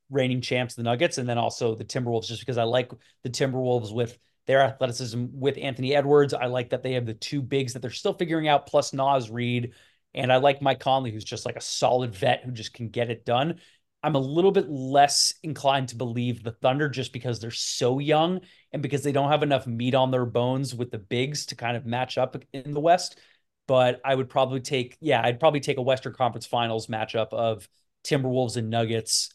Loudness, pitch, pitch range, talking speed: -25 LUFS, 130 Hz, 120-140 Hz, 220 wpm